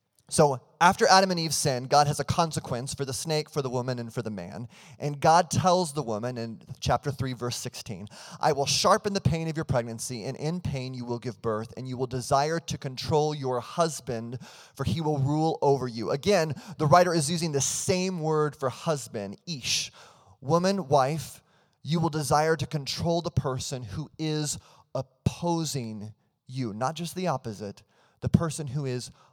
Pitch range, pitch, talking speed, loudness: 125-160 Hz, 145 Hz, 185 wpm, -27 LUFS